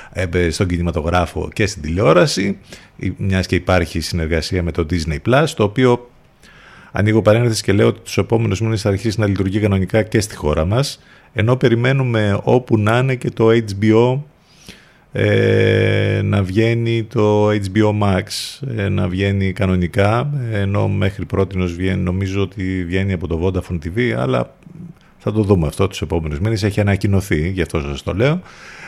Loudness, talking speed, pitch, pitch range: -17 LUFS, 160 wpm, 100 Hz, 95-115 Hz